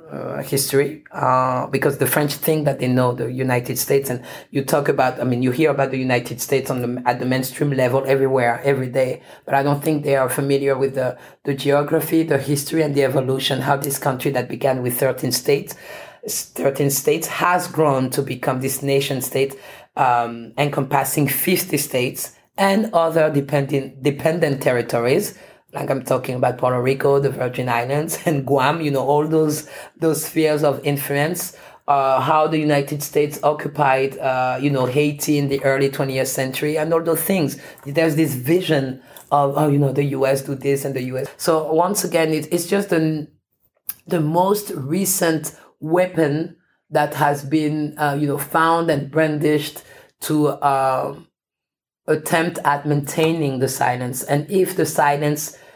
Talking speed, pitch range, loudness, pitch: 170 wpm, 135-155 Hz, -19 LUFS, 145 Hz